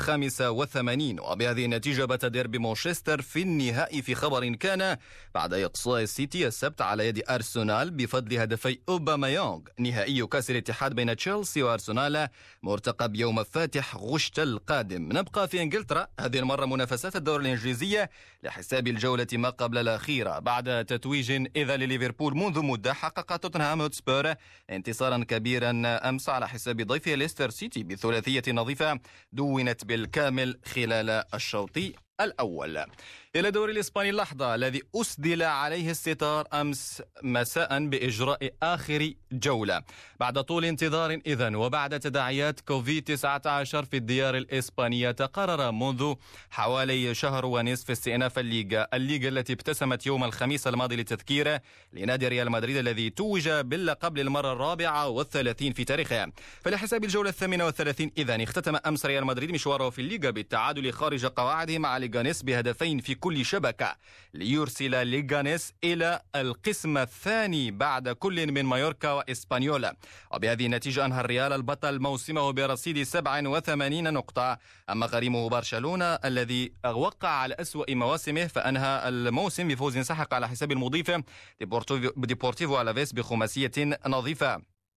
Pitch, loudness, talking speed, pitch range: 135 Hz, -29 LUFS, 125 wpm, 120-150 Hz